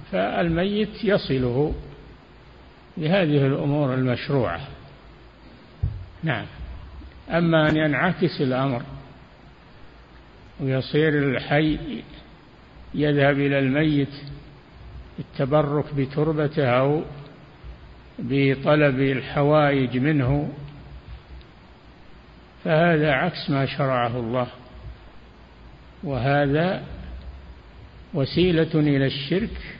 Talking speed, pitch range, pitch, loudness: 60 wpm, 125-150 Hz, 140 Hz, -22 LUFS